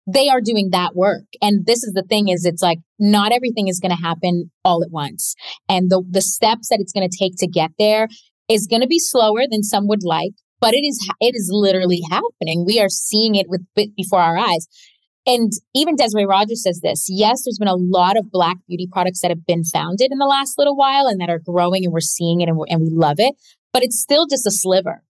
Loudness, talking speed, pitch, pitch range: -17 LUFS, 245 wpm, 195 Hz, 180-230 Hz